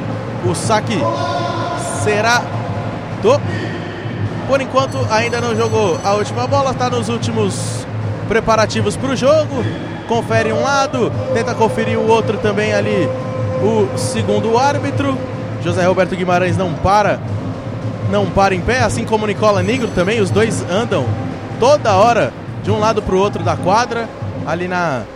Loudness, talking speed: -16 LUFS, 145 wpm